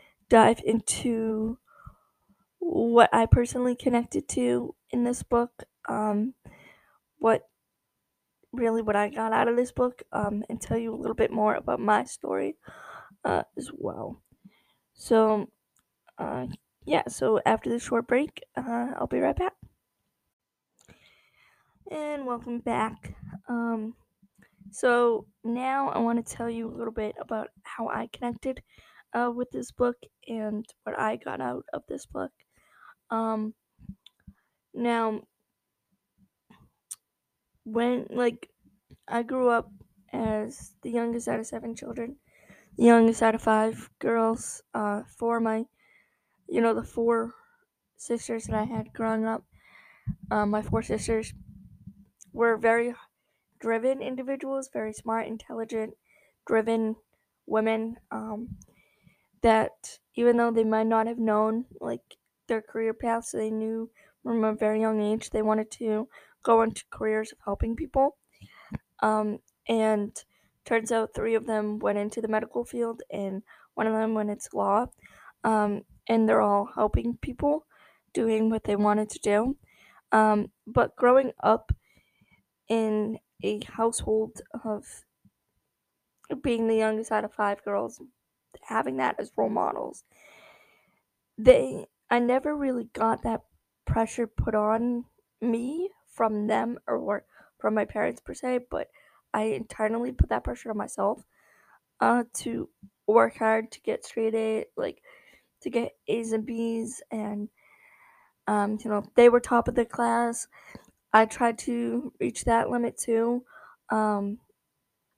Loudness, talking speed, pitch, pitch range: -27 LUFS, 135 wpm, 225 Hz, 220-240 Hz